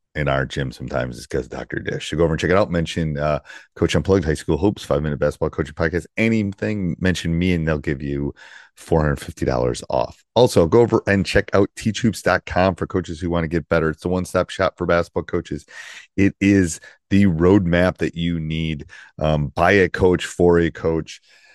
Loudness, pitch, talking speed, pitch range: -20 LUFS, 85 Hz, 200 wpm, 75-90 Hz